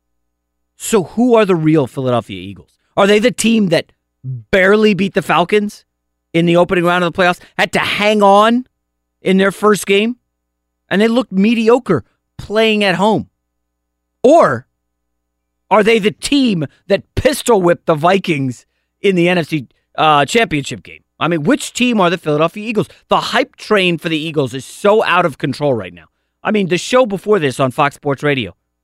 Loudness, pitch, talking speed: -14 LUFS, 170 Hz, 175 wpm